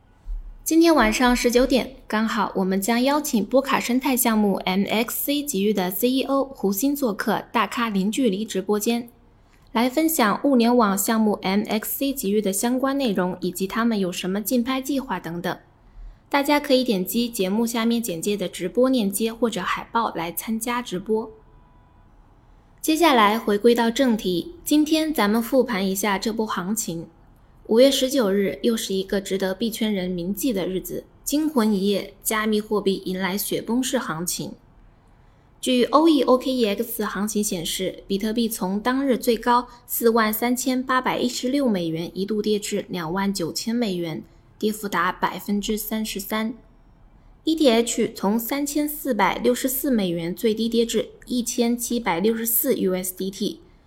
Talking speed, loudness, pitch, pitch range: 255 characters per minute, -22 LUFS, 225 Hz, 195-250 Hz